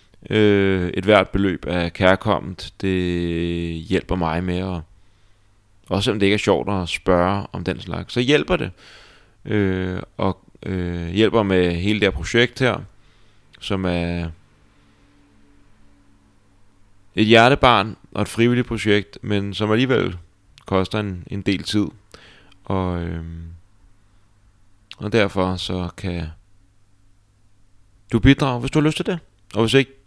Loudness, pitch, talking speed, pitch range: -20 LUFS, 100 Hz, 135 wpm, 90-105 Hz